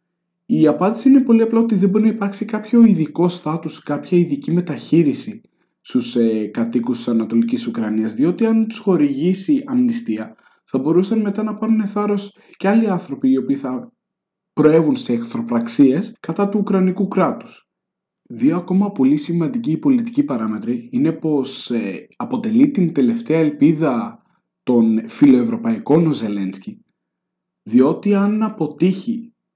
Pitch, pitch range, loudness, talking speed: 185 Hz, 145-225 Hz, -18 LUFS, 130 wpm